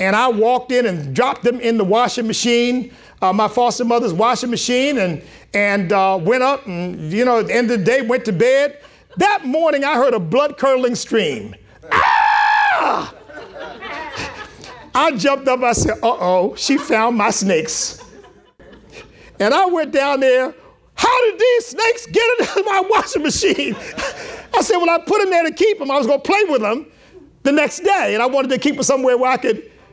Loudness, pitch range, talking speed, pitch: -16 LUFS, 230-320 Hz, 195 wpm, 255 Hz